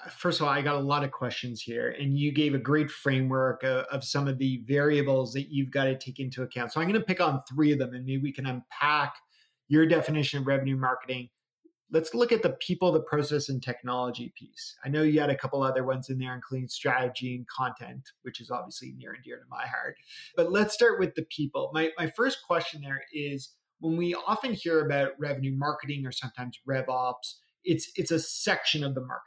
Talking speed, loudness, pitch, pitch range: 230 wpm, -29 LUFS, 140 Hz, 130-160 Hz